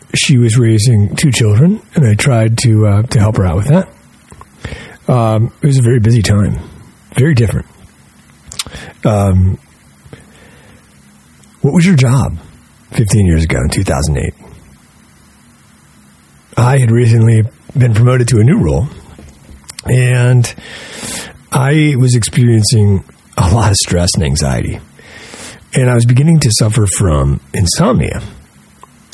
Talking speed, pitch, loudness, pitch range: 130 wpm, 115 Hz, -11 LUFS, 95-125 Hz